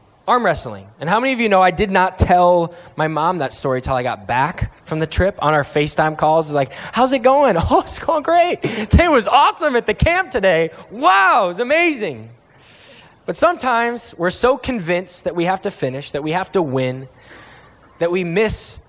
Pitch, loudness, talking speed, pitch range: 180 Hz, -17 LUFS, 205 wpm, 150-235 Hz